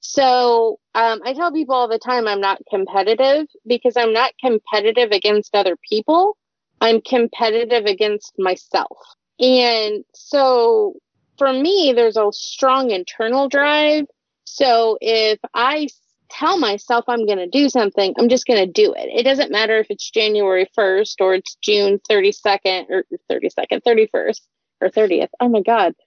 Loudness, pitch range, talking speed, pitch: -17 LUFS, 210-265 Hz, 145 wpm, 230 Hz